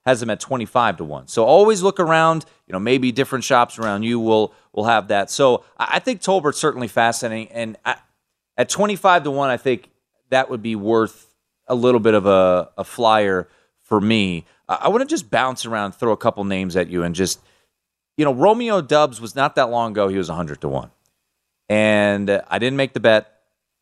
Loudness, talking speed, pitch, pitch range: -19 LUFS, 210 wpm, 115 Hz, 105-140 Hz